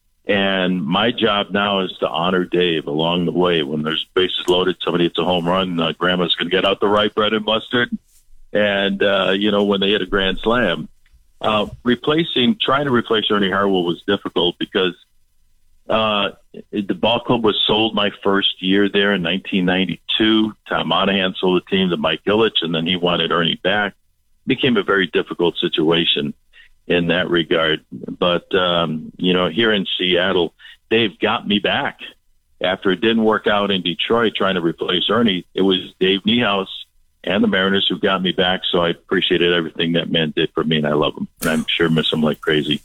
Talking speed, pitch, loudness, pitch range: 195 wpm, 95 Hz, -18 LUFS, 85-100 Hz